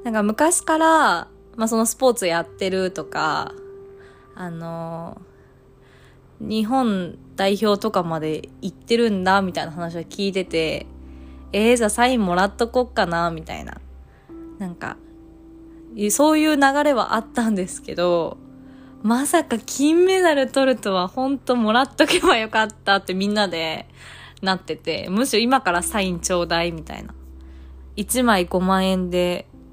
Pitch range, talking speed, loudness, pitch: 170-255 Hz, 280 characters per minute, -20 LUFS, 205 Hz